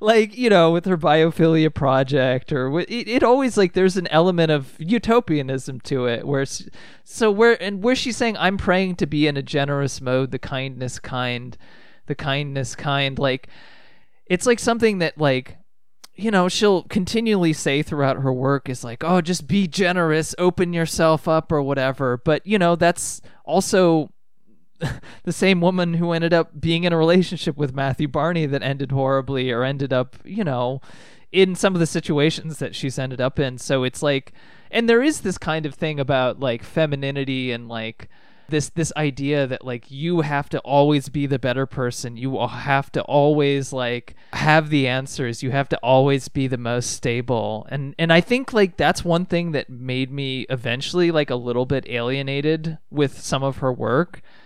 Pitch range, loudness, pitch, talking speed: 130-170 Hz, -21 LUFS, 145 Hz, 185 wpm